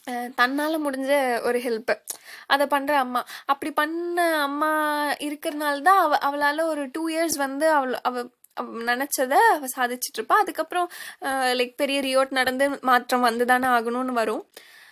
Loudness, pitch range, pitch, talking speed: -23 LUFS, 250-315 Hz, 280 Hz, 135 wpm